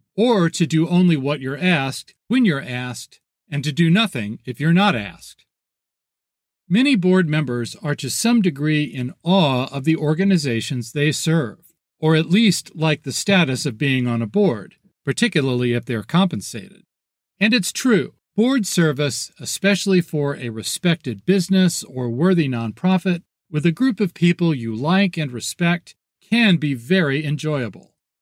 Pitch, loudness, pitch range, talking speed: 160 Hz, -19 LUFS, 135-190 Hz, 155 wpm